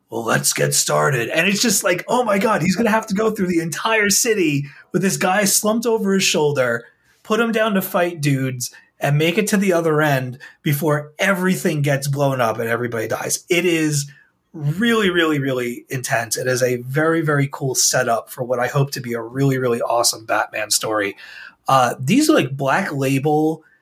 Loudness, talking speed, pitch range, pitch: -18 LUFS, 200 wpm, 135-195 Hz, 155 Hz